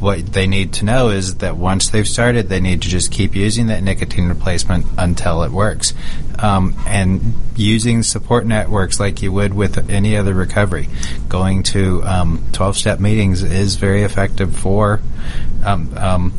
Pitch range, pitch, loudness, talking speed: 95-105 Hz, 100 Hz, -17 LUFS, 165 wpm